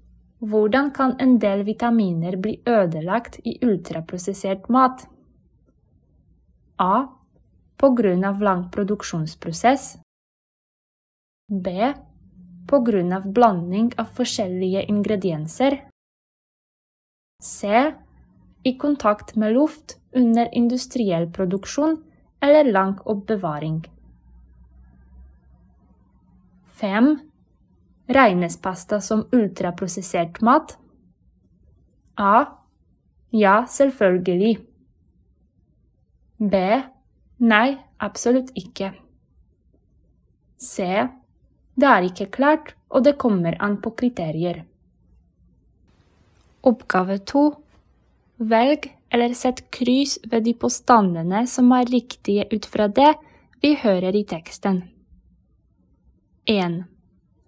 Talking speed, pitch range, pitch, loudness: 80 wpm, 185-250 Hz, 215 Hz, -21 LUFS